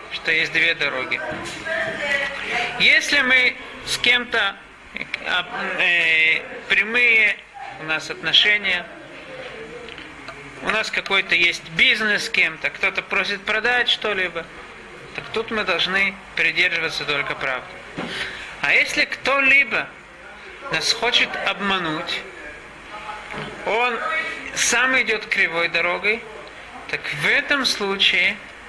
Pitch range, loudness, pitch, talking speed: 180-245 Hz, -19 LUFS, 205 Hz, 100 wpm